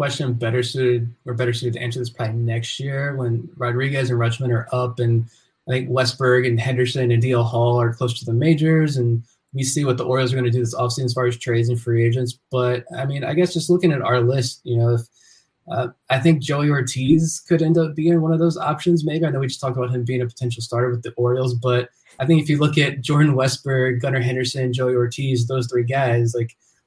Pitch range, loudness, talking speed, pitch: 120-140 Hz, -20 LUFS, 245 wpm, 125 Hz